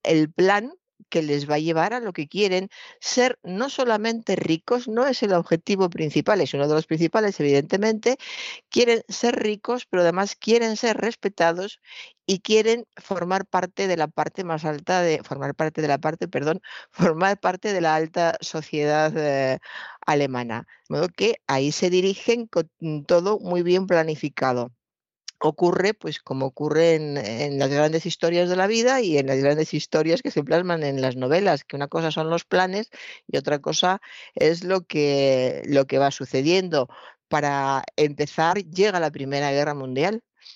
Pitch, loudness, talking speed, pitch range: 170 Hz, -23 LUFS, 170 wpm, 150-200 Hz